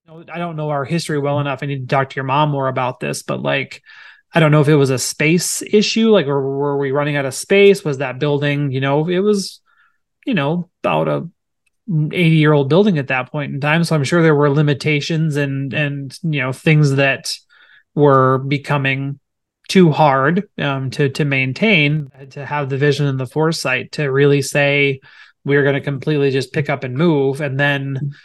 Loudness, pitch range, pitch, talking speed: -16 LUFS, 140-160 Hz, 145 Hz, 210 wpm